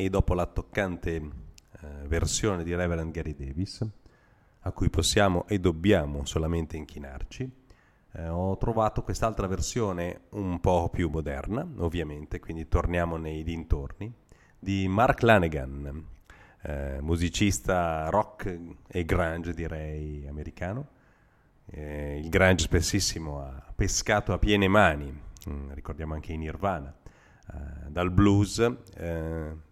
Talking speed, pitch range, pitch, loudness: 115 wpm, 80-100 Hz, 85 Hz, -28 LUFS